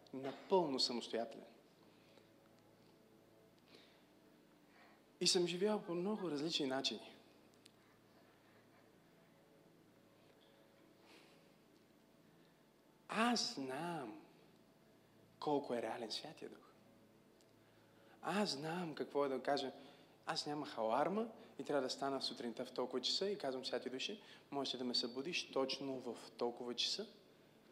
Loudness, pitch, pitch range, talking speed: -41 LUFS, 135 Hz, 120-170 Hz, 95 wpm